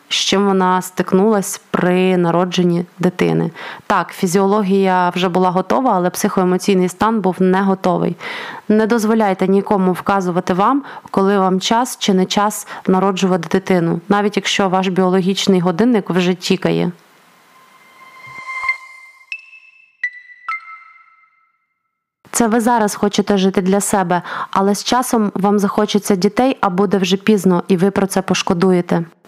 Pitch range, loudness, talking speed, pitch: 185-235 Hz, -16 LUFS, 125 wpm, 200 Hz